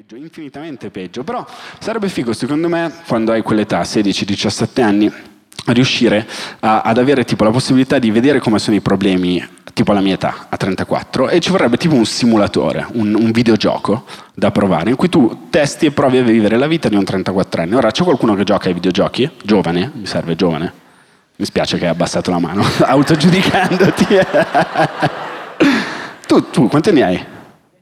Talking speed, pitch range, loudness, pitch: 175 wpm, 100-135 Hz, -14 LUFS, 110 Hz